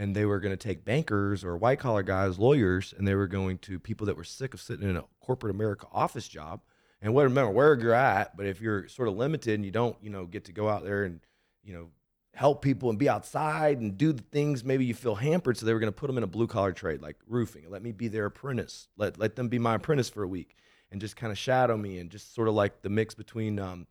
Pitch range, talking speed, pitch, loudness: 100-120 Hz, 270 wpm, 110 Hz, -29 LUFS